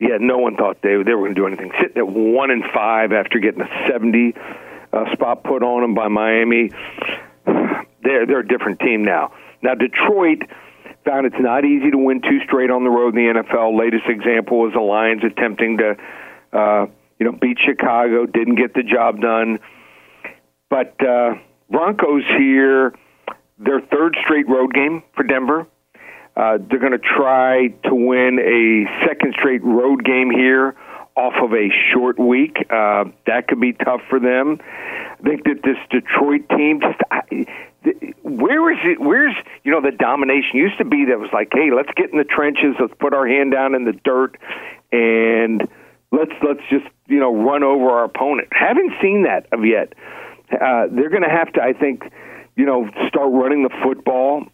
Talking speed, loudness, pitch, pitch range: 180 wpm, -16 LUFS, 130 Hz, 115-145 Hz